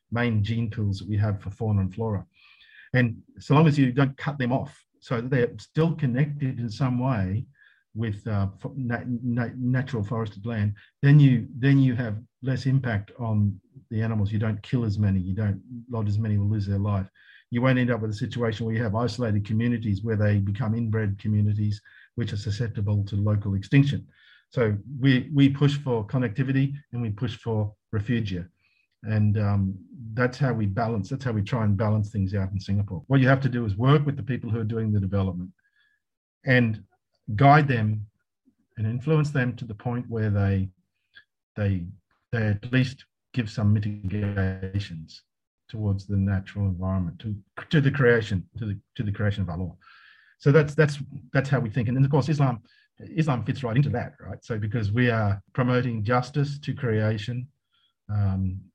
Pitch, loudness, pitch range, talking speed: 115 Hz, -25 LUFS, 105-130 Hz, 190 wpm